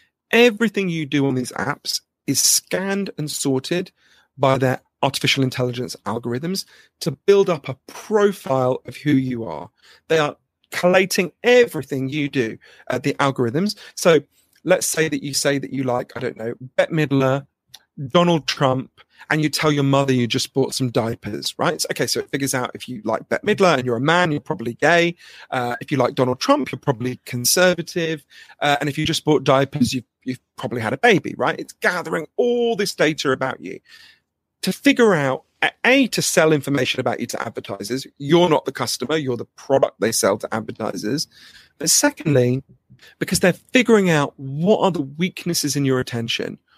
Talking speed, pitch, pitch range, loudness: 180 wpm, 145 Hz, 130-180 Hz, -20 LUFS